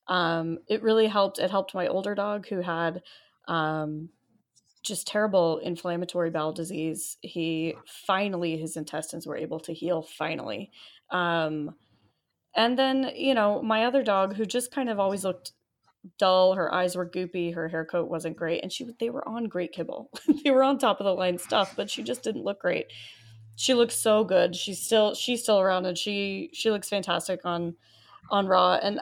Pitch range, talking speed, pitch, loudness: 165-215 Hz, 185 wpm, 185 Hz, -27 LUFS